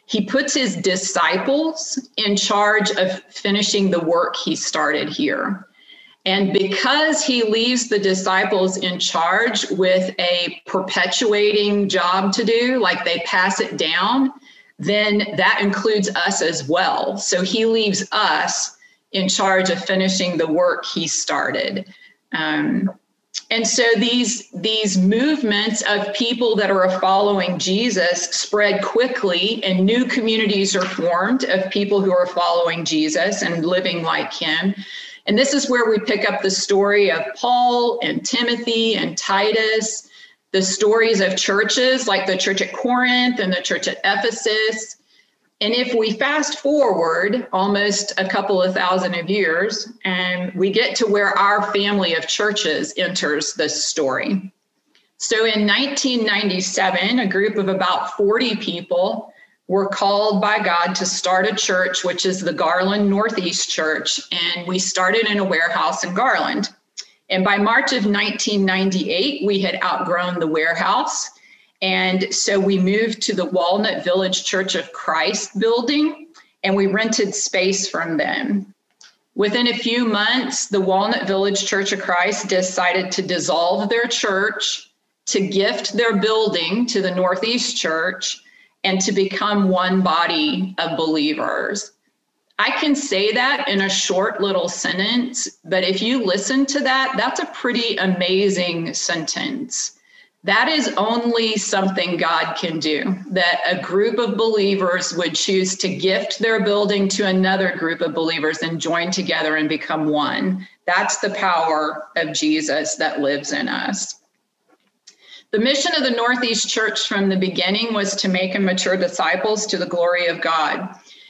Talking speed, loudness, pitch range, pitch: 150 wpm, -18 LUFS, 185-225 Hz, 200 Hz